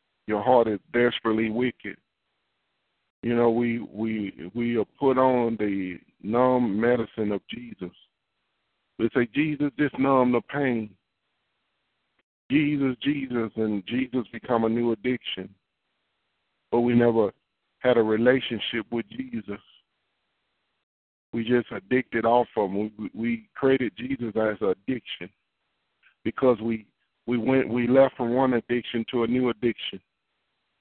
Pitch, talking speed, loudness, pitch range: 120 Hz, 130 wpm, -25 LUFS, 110-125 Hz